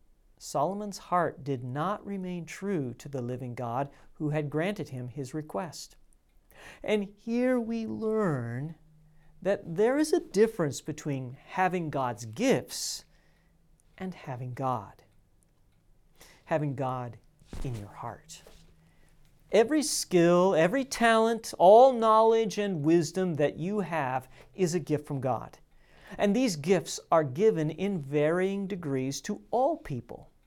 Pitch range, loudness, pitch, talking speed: 135-200 Hz, -28 LUFS, 160 Hz, 125 wpm